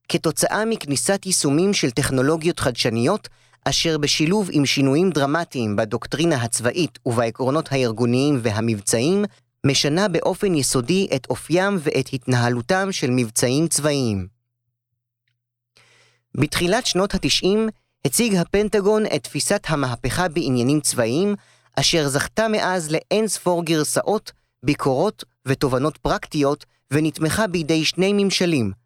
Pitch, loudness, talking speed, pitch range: 150 Hz, -20 LUFS, 100 wpm, 125-180 Hz